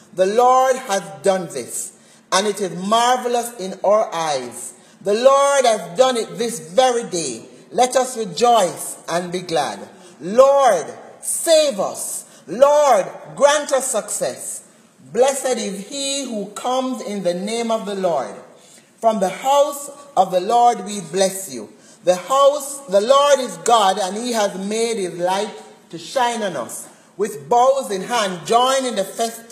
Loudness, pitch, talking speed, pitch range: -18 LUFS, 225 Hz, 155 wpm, 190-260 Hz